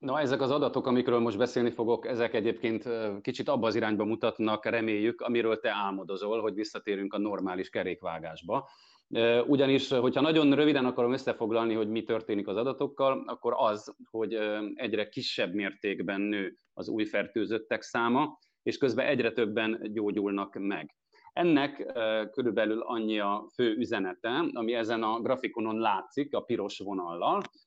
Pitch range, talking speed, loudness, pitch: 110-120 Hz, 145 wpm, -30 LUFS, 115 Hz